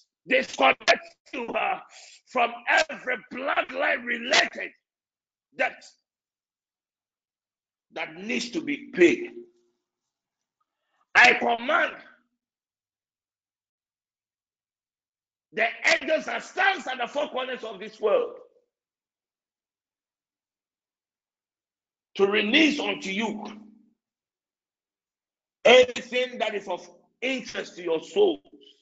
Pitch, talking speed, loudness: 235 Hz, 80 wpm, -24 LUFS